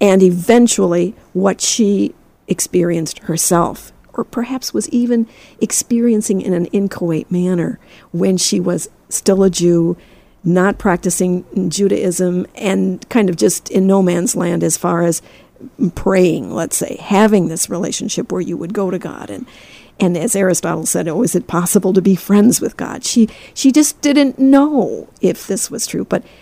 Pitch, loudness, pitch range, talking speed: 190 Hz, -15 LUFS, 175-215 Hz, 160 wpm